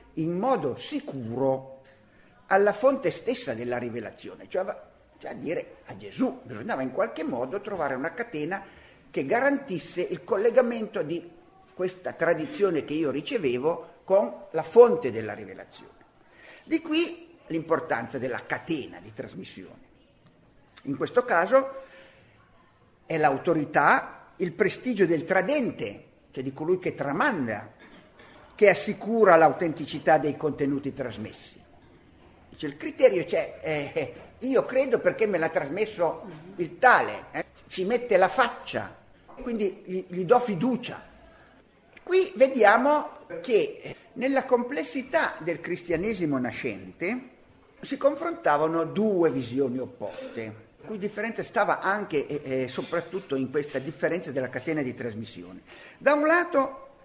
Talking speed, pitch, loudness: 125 wpm, 185 Hz, -26 LUFS